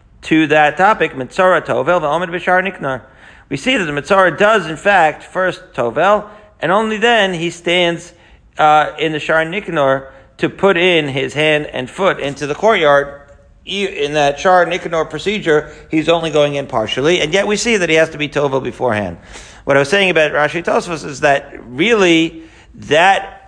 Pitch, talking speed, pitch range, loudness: 160 Hz, 175 wpm, 145-185 Hz, -14 LUFS